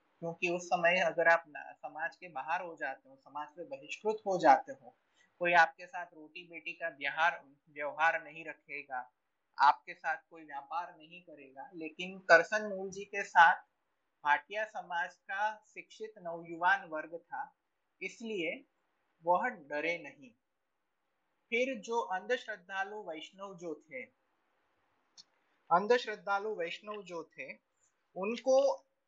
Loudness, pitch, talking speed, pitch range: -33 LUFS, 175 Hz, 120 wpm, 160-215 Hz